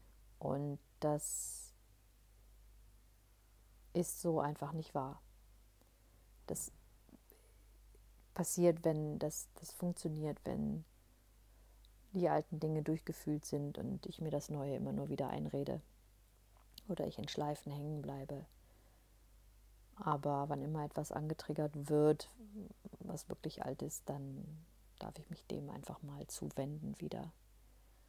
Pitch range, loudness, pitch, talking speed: 100-155 Hz, -41 LUFS, 140 Hz, 115 wpm